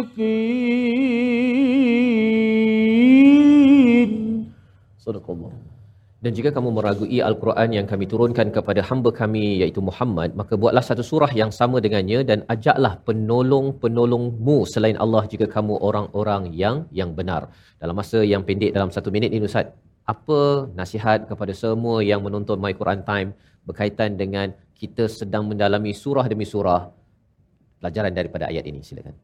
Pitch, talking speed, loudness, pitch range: 110 Hz, 130 wpm, -20 LUFS, 100-130 Hz